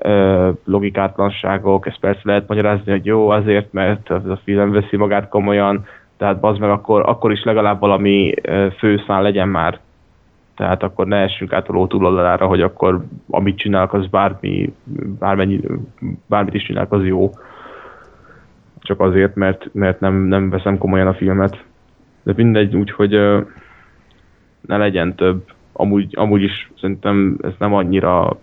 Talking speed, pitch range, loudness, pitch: 140 wpm, 95-105 Hz, -16 LUFS, 100 Hz